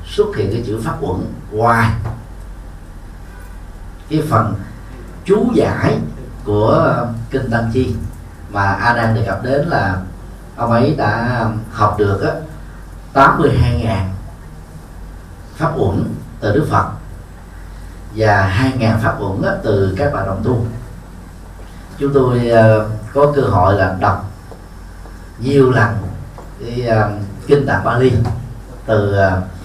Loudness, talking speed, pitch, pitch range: -15 LUFS, 120 wpm, 105 Hz, 95-120 Hz